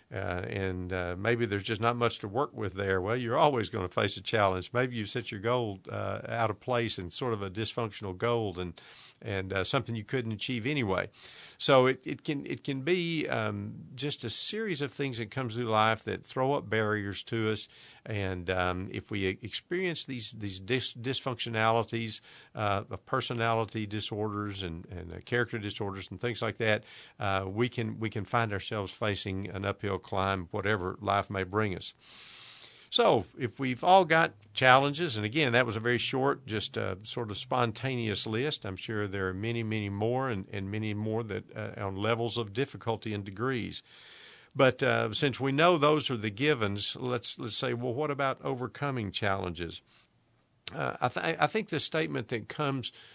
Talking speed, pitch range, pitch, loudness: 190 wpm, 100-125 Hz, 110 Hz, -31 LUFS